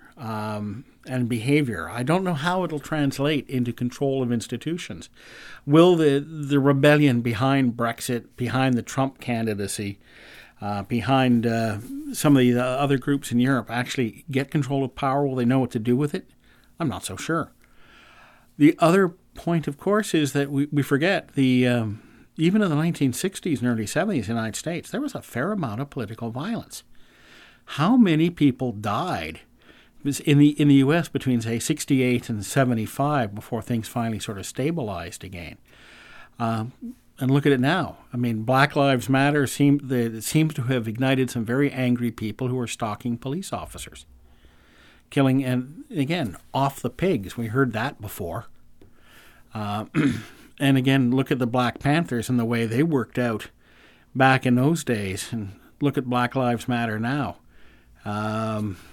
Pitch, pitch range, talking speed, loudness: 130 Hz, 115-145 Hz, 165 wpm, -23 LUFS